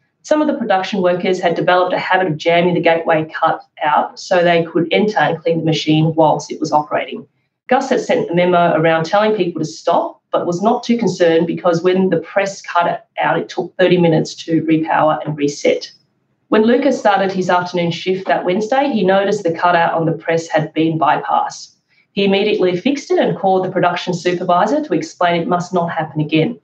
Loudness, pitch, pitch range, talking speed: -16 LUFS, 175 Hz, 165-195 Hz, 205 wpm